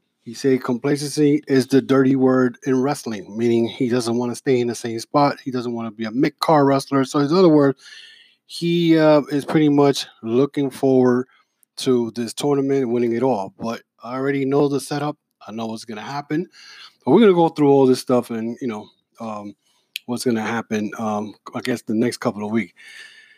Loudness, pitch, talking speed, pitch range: -19 LUFS, 130 Hz, 210 wpm, 115-145 Hz